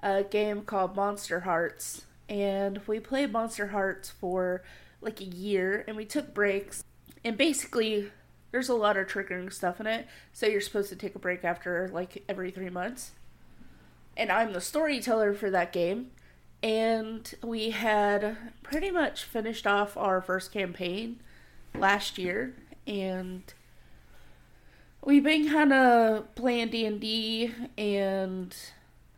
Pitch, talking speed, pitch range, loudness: 205 Hz, 140 wpm, 185-225 Hz, -29 LUFS